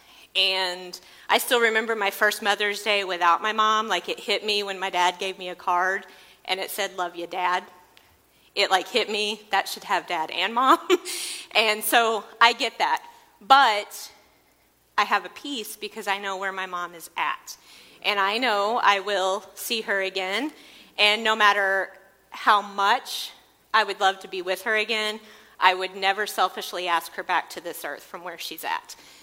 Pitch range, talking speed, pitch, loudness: 190-220 Hz, 185 wpm, 200 Hz, -23 LUFS